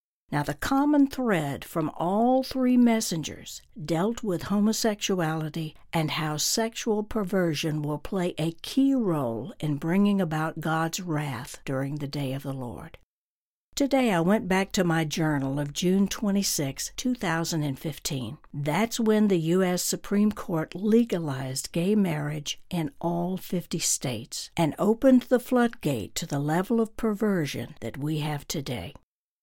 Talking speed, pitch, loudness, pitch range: 140 wpm, 170 Hz, -27 LUFS, 150-210 Hz